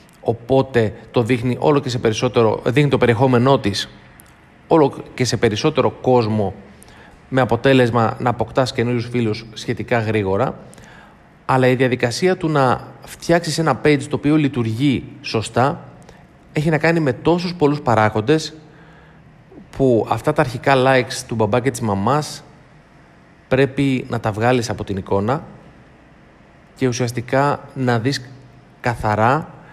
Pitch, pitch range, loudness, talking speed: 130 Hz, 115-145 Hz, -18 LUFS, 130 wpm